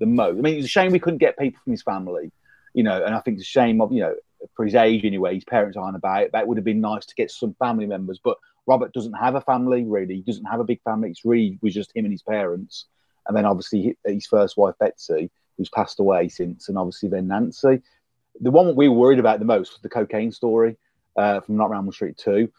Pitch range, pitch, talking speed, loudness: 105-140 Hz, 115 Hz, 265 wpm, -21 LUFS